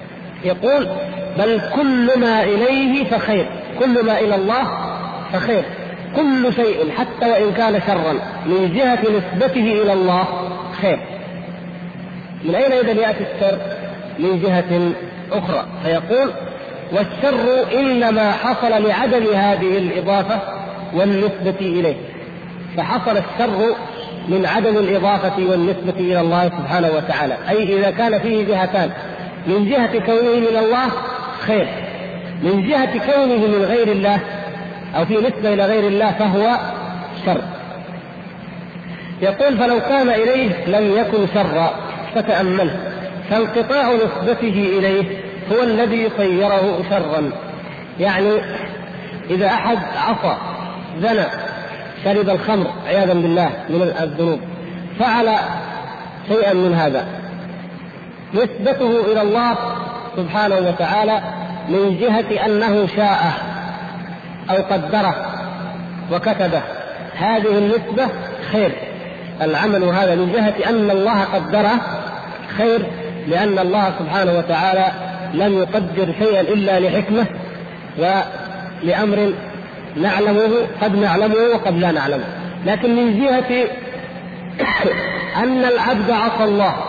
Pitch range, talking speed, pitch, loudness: 185-225 Hz, 105 wpm, 200 Hz, -17 LUFS